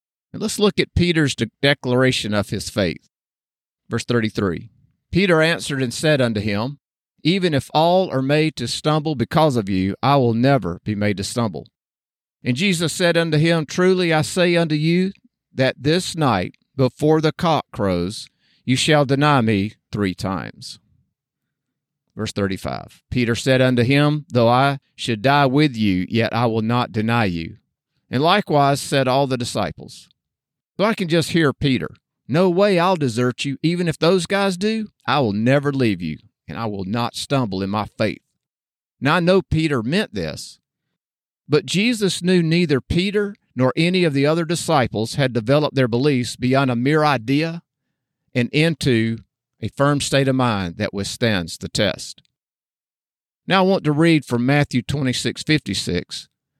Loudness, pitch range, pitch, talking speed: -19 LUFS, 115-160 Hz, 140 Hz, 165 wpm